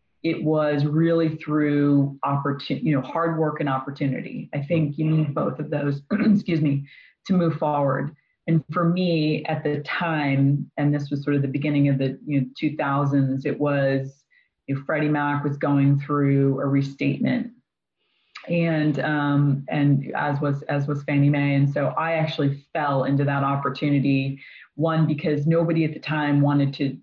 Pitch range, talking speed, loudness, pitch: 140-155 Hz, 170 wpm, -23 LUFS, 145 Hz